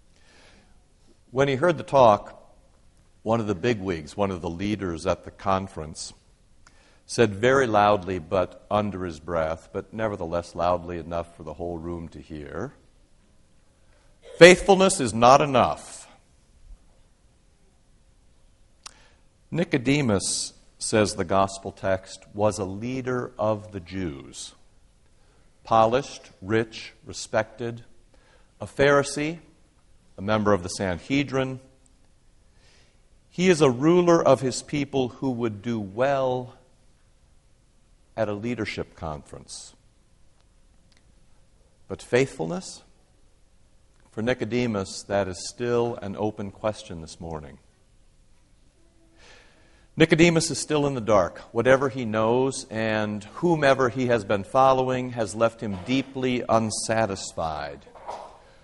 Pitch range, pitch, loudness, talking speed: 90-125 Hz, 105 Hz, -24 LUFS, 105 wpm